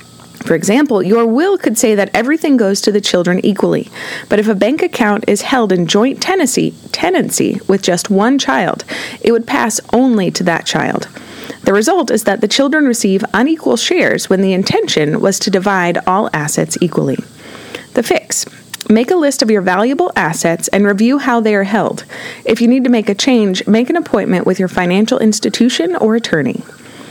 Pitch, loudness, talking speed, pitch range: 220 Hz, -13 LUFS, 185 wpm, 195-250 Hz